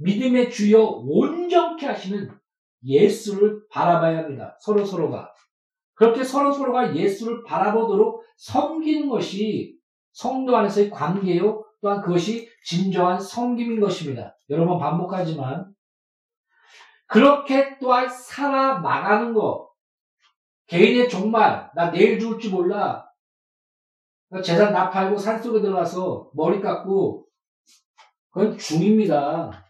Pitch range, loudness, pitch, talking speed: 185-250 Hz, -21 LUFS, 210 Hz, 255 characters per minute